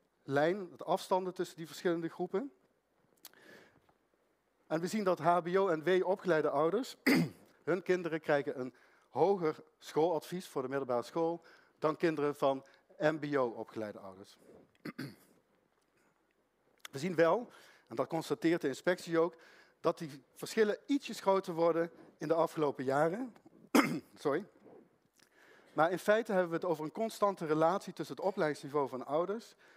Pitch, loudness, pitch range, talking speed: 165 Hz, -34 LUFS, 145-180 Hz, 135 wpm